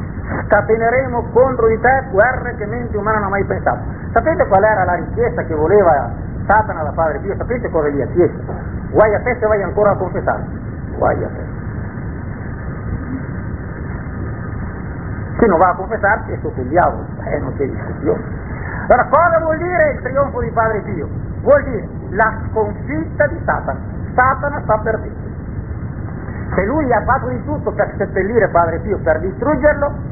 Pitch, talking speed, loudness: 215 Hz, 165 wpm, -17 LUFS